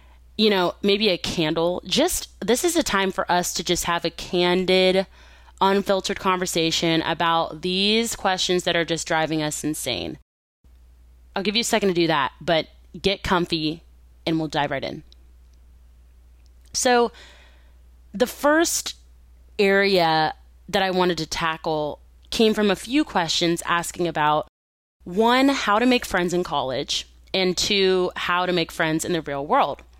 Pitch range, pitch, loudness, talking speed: 140-190 Hz, 170 Hz, -22 LUFS, 155 wpm